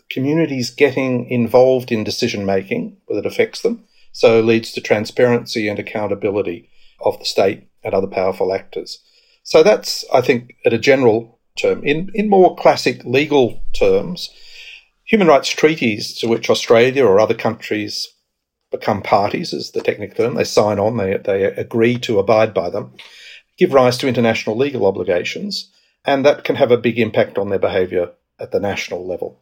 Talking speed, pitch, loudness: 165 wpm, 180 Hz, -17 LUFS